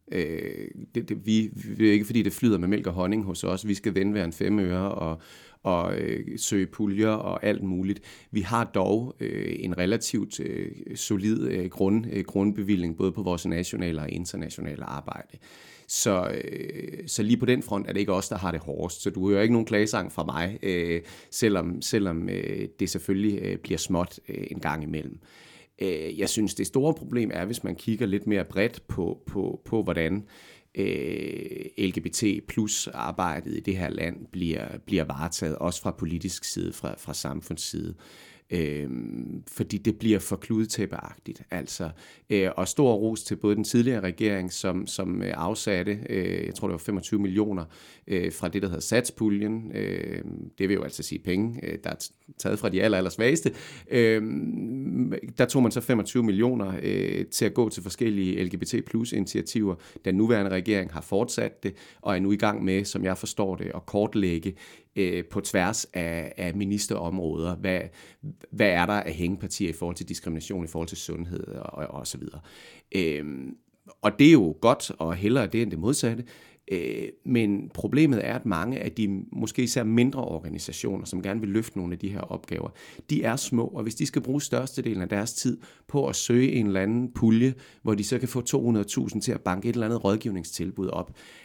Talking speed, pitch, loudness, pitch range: 185 wpm, 100 Hz, -27 LUFS, 90-110 Hz